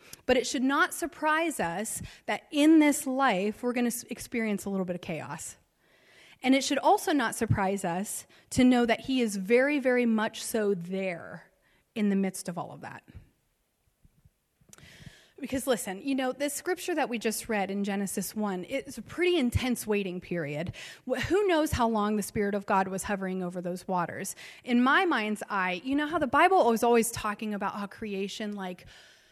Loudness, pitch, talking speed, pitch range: -28 LUFS, 225 Hz, 185 wpm, 195-270 Hz